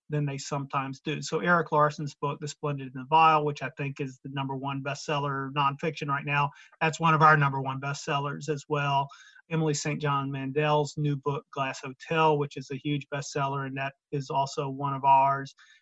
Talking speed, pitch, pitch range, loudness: 200 wpm, 145 Hz, 140-150 Hz, -28 LUFS